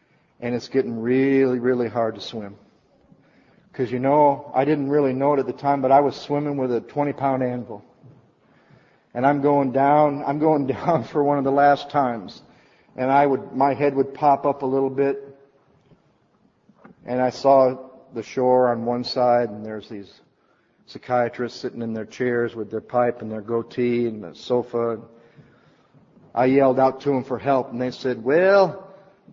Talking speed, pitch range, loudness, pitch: 180 wpm, 120-140 Hz, -21 LUFS, 130 Hz